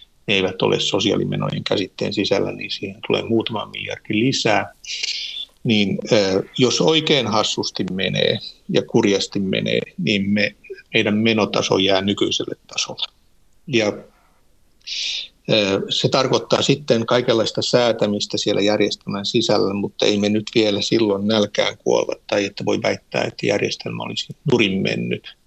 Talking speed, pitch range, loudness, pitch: 125 wpm, 100-110 Hz, -20 LUFS, 105 Hz